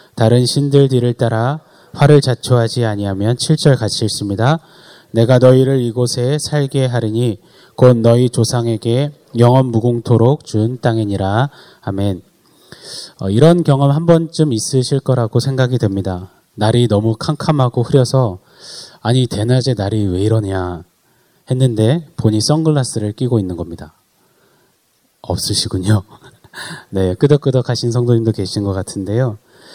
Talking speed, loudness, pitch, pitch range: 280 characters per minute, -15 LUFS, 120 Hz, 110-135 Hz